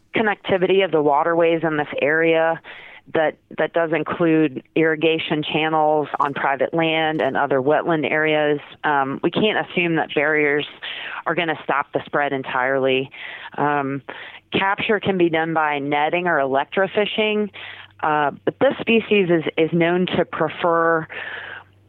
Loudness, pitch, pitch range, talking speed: -20 LUFS, 160 Hz, 150-175 Hz, 135 wpm